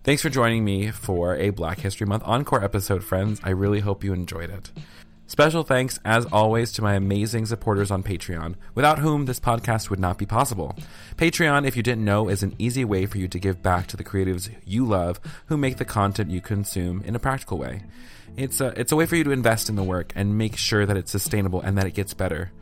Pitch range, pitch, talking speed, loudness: 95-120 Hz, 105 Hz, 235 wpm, -23 LUFS